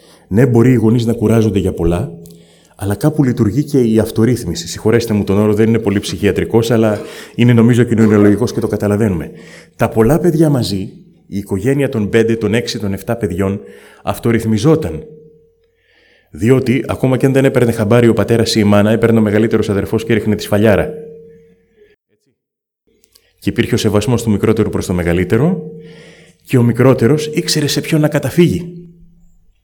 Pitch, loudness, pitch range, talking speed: 115 Hz, -13 LUFS, 105-145 Hz, 160 wpm